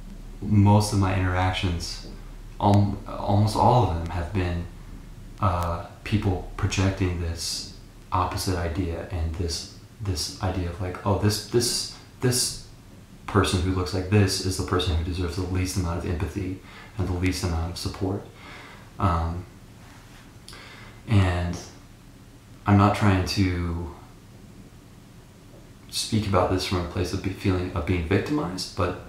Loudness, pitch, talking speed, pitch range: -25 LUFS, 95 Hz, 135 wpm, 90-105 Hz